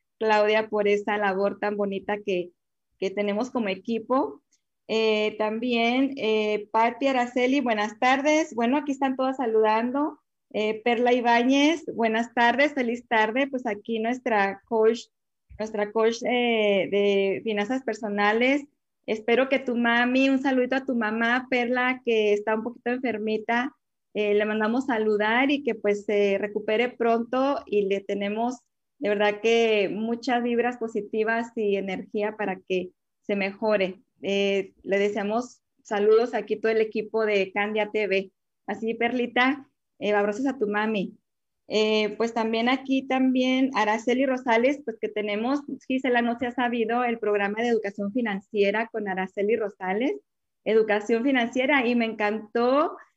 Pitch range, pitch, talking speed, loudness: 210-245 Hz, 225 Hz, 145 wpm, -25 LUFS